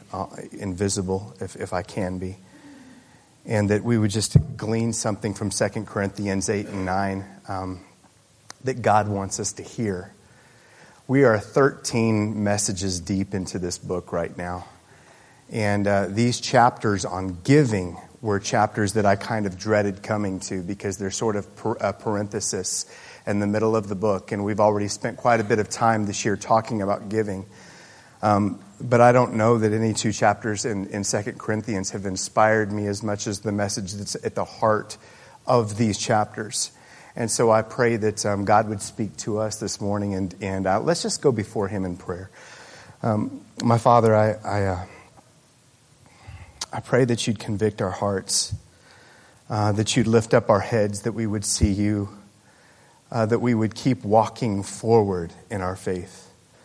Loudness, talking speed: -23 LUFS, 180 wpm